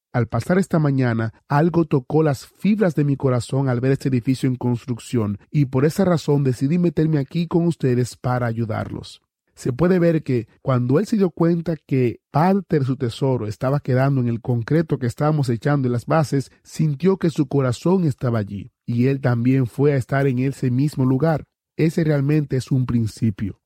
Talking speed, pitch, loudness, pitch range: 190 wpm, 135 Hz, -20 LUFS, 125-155 Hz